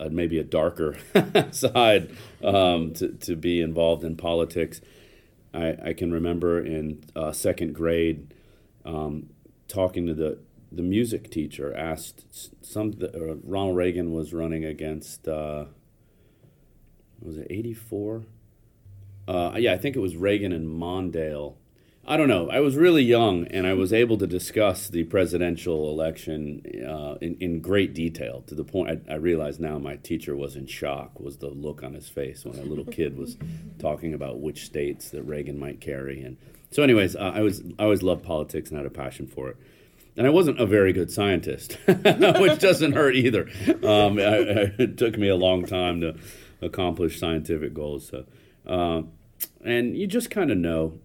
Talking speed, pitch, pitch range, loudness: 175 wpm, 85 Hz, 75-95 Hz, -25 LUFS